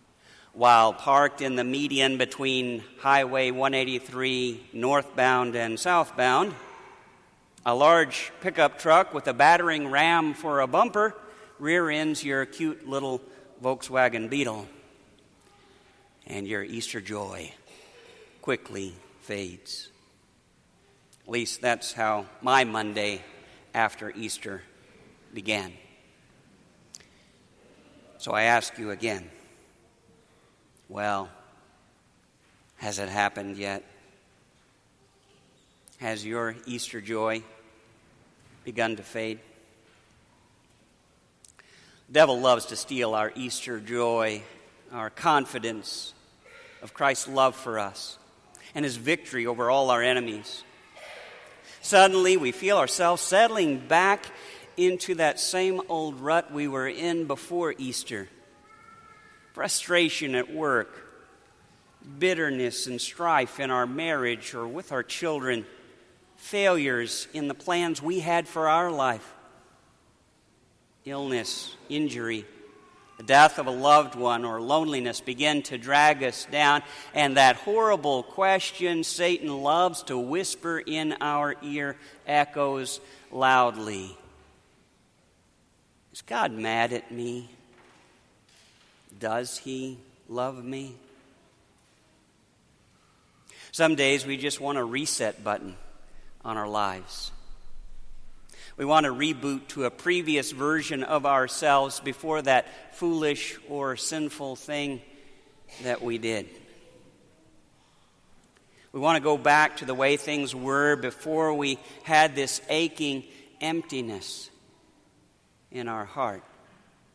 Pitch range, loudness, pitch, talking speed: 120-150 Hz, -26 LUFS, 135 Hz, 105 wpm